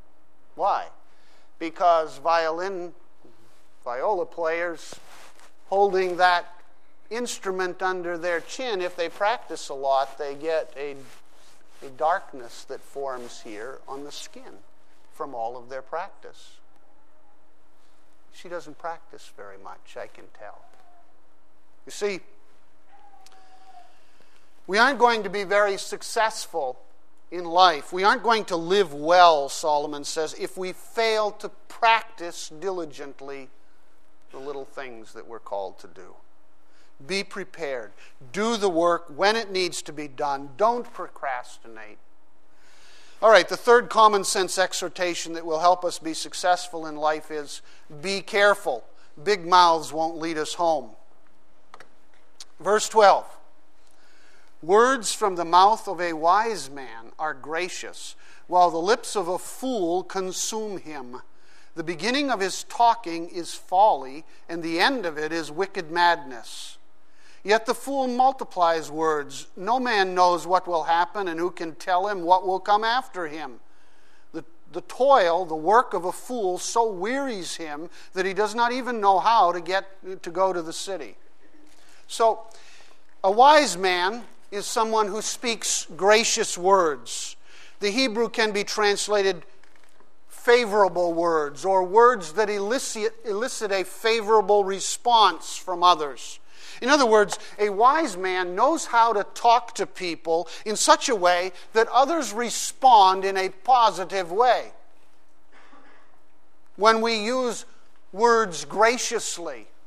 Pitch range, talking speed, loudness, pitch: 165-220 Hz, 135 wpm, -23 LUFS, 185 Hz